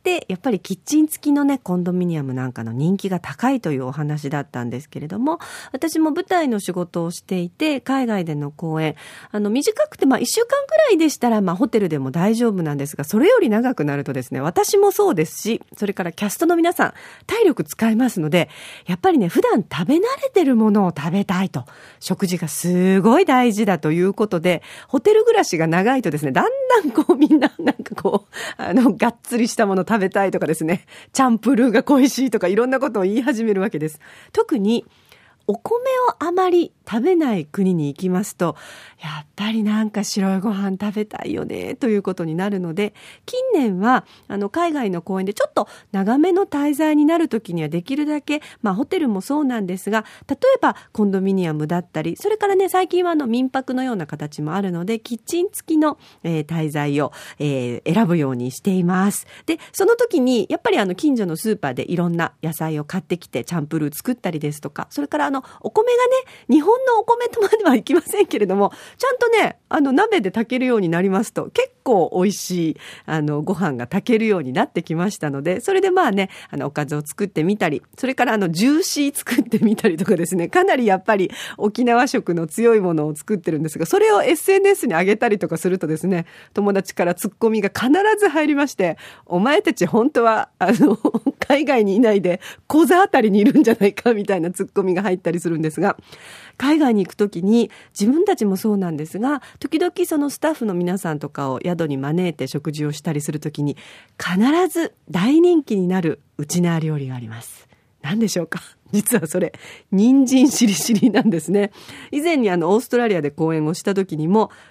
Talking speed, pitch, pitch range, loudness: 405 characters per minute, 210 Hz, 175-280 Hz, -19 LUFS